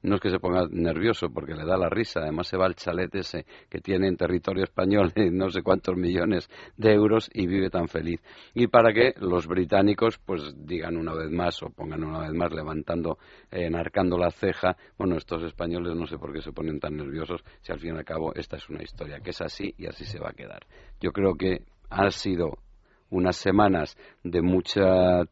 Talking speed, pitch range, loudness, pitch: 215 wpm, 85-95 Hz, -26 LUFS, 90 Hz